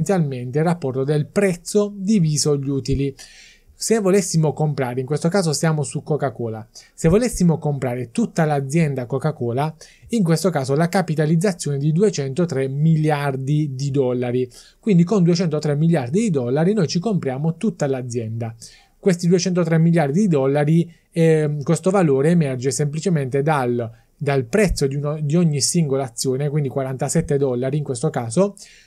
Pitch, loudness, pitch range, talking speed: 150 Hz, -20 LUFS, 135-175 Hz, 145 wpm